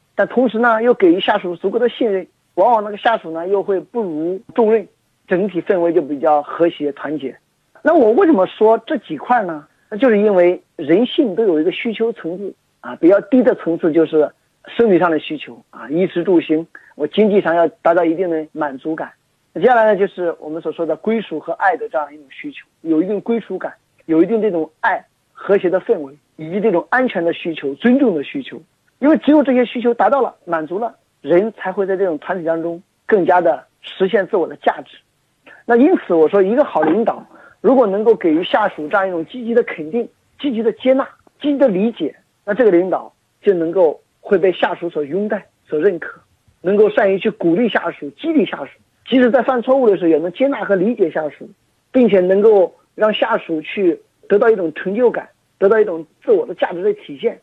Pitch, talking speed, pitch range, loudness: 200 Hz, 310 characters per minute, 170-245 Hz, -16 LUFS